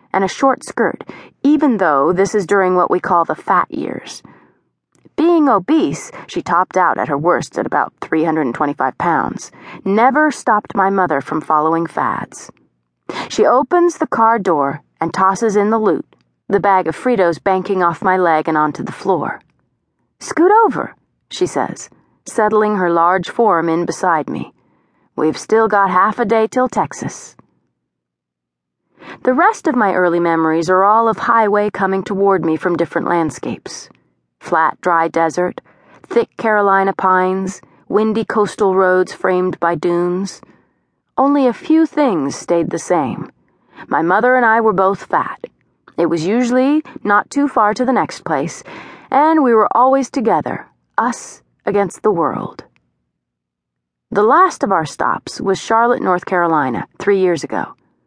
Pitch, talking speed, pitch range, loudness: 190 Hz, 155 wpm, 165-235 Hz, -15 LUFS